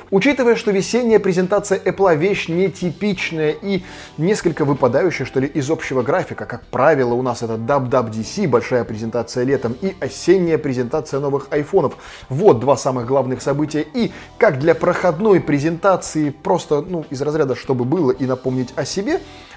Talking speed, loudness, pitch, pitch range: 150 wpm, -18 LUFS, 155 Hz, 130-185 Hz